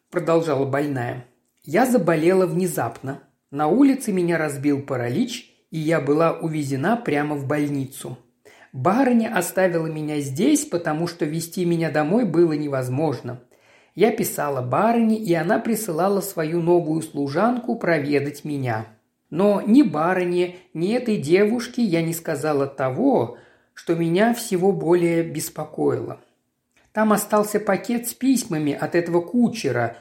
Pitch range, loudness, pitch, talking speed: 145-205 Hz, -21 LUFS, 165 Hz, 125 wpm